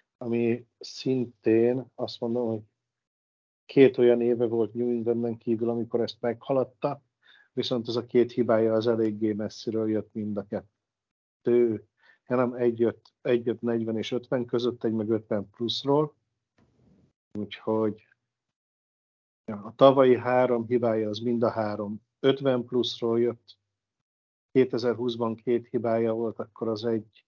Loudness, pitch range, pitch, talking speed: -27 LUFS, 110-120 Hz, 115 Hz, 130 wpm